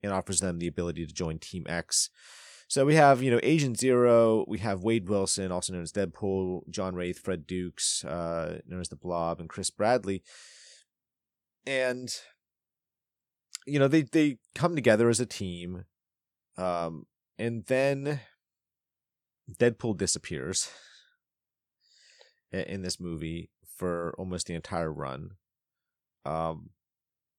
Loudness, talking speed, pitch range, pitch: -29 LUFS, 130 wpm, 85-120 Hz, 95 Hz